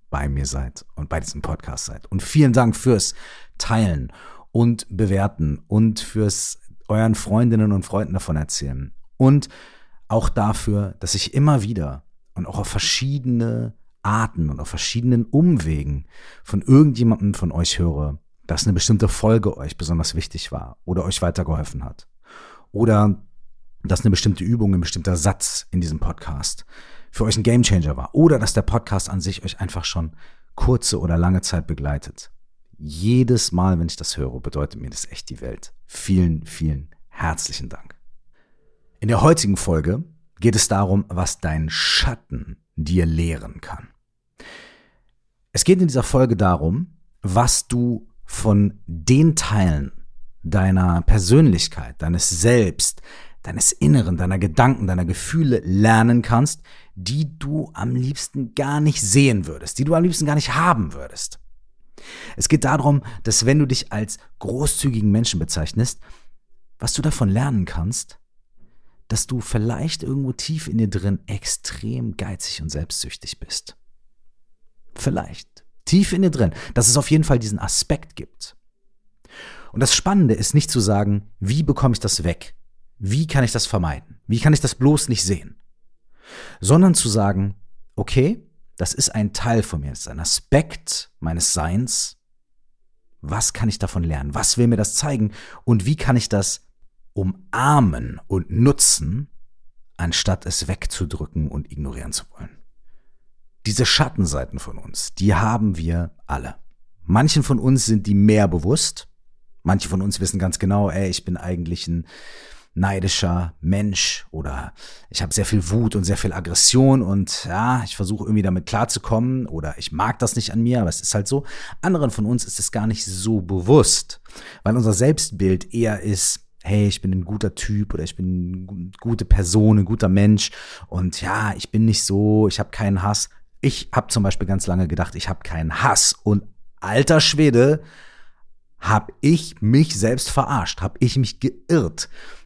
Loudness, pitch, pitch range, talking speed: -20 LUFS, 100 Hz, 90-120 Hz, 160 wpm